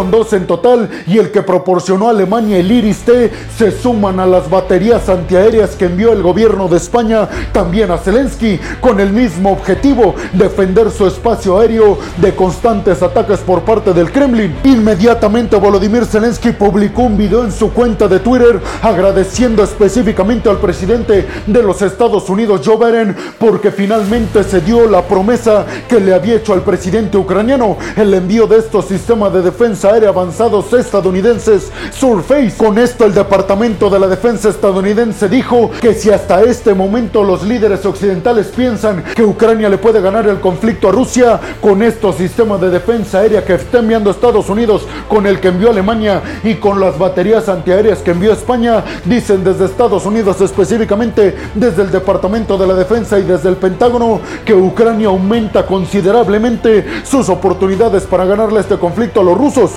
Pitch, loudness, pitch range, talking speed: 210 Hz, -11 LUFS, 190-230 Hz, 165 wpm